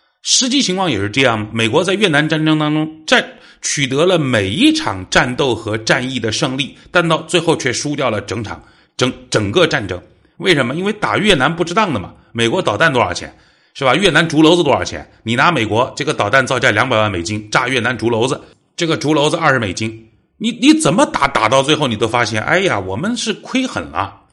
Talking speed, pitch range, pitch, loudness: 320 characters per minute, 115-180 Hz, 150 Hz, -15 LUFS